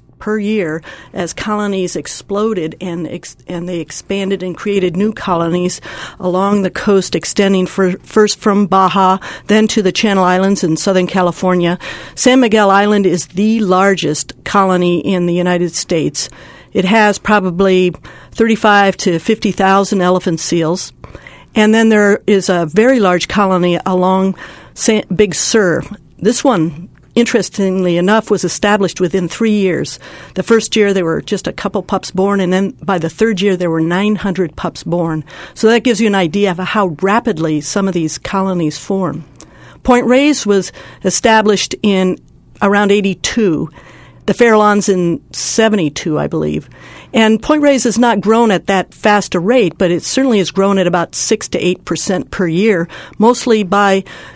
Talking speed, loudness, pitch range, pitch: 160 wpm, -13 LUFS, 175-210 Hz, 190 Hz